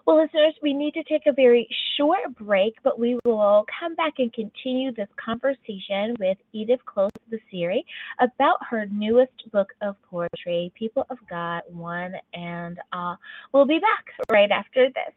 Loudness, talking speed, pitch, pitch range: -23 LUFS, 165 wpm, 235 Hz, 200-275 Hz